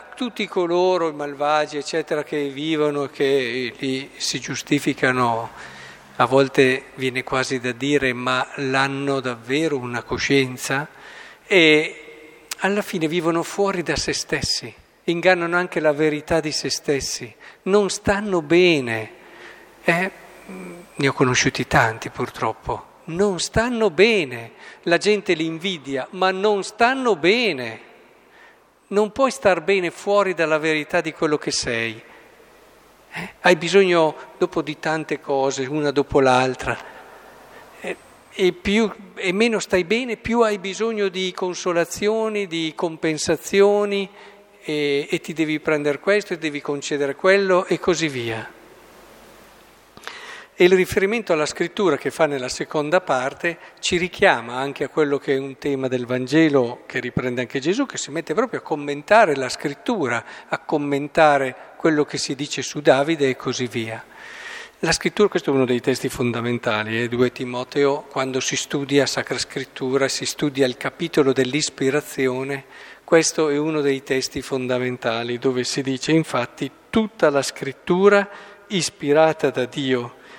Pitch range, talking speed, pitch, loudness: 135-180 Hz, 140 wpm, 150 Hz, -21 LUFS